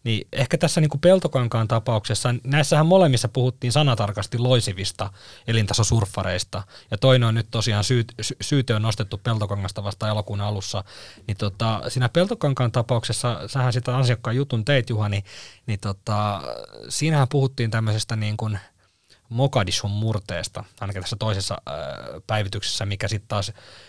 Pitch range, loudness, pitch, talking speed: 105-125 Hz, -23 LUFS, 110 Hz, 135 wpm